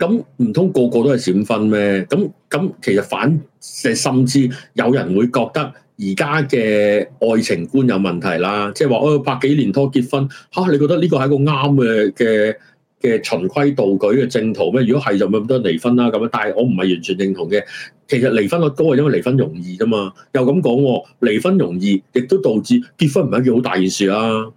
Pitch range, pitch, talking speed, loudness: 105-145 Hz, 125 Hz, 300 characters per minute, -16 LUFS